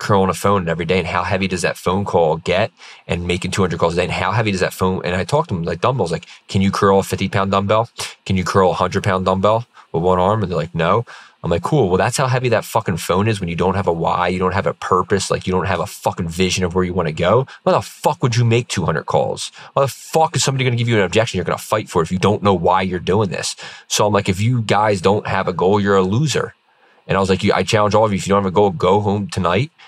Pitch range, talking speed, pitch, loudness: 90-105 Hz, 305 wpm, 95 Hz, -18 LUFS